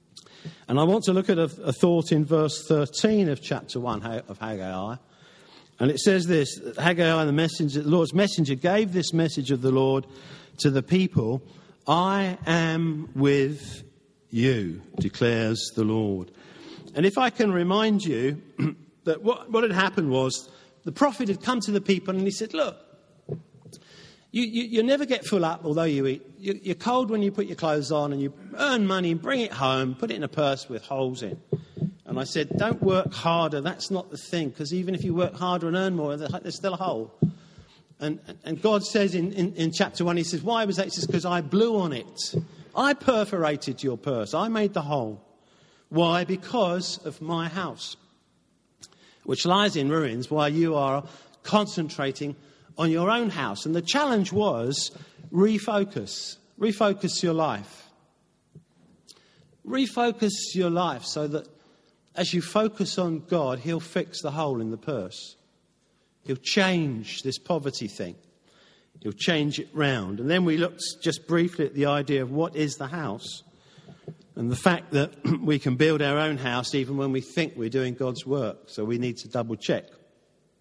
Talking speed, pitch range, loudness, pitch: 180 wpm, 140-190 Hz, -26 LUFS, 165 Hz